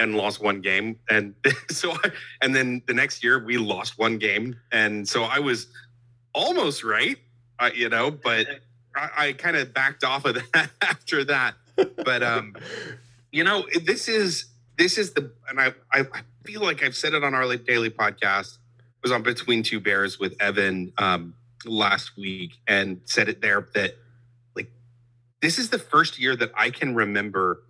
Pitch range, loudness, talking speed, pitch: 110-135 Hz, -23 LUFS, 180 wpm, 120 Hz